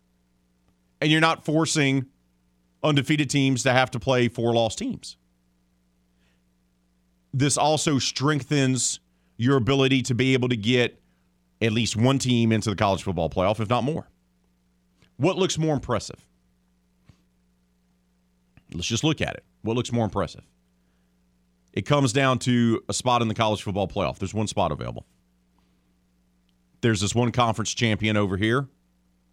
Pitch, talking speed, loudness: 100 Hz, 145 wpm, -23 LUFS